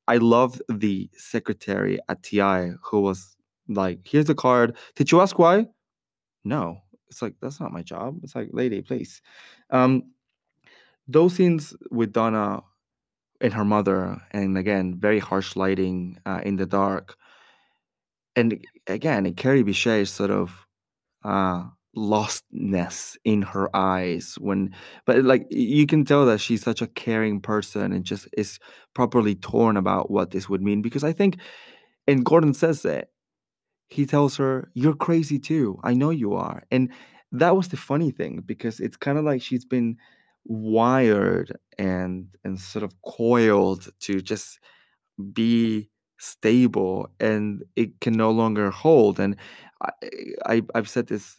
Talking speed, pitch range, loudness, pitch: 150 wpm, 100-130 Hz, -23 LUFS, 110 Hz